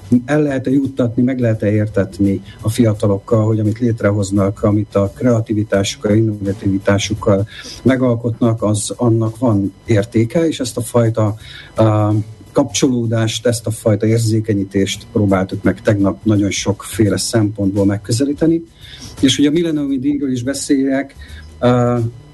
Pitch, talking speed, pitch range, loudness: 110 Hz, 120 wpm, 100-120 Hz, -16 LUFS